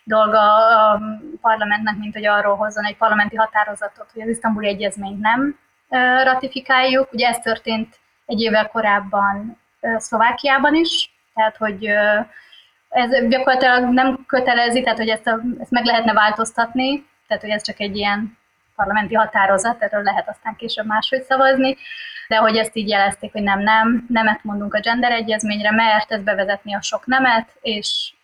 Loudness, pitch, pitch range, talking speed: -17 LUFS, 220 Hz, 210-250 Hz, 155 wpm